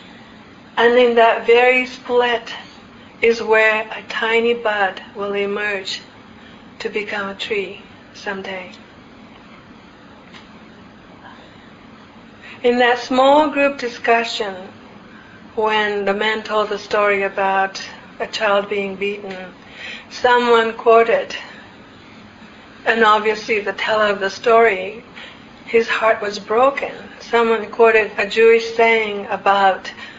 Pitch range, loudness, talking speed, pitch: 205-235 Hz, -17 LUFS, 105 wpm, 220 Hz